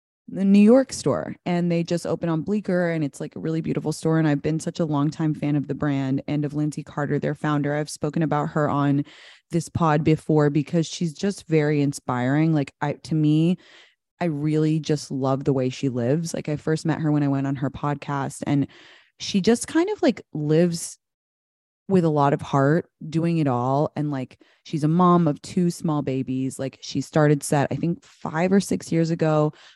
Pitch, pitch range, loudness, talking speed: 150 Hz, 145-165 Hz, -23 LUFS, 210 wpm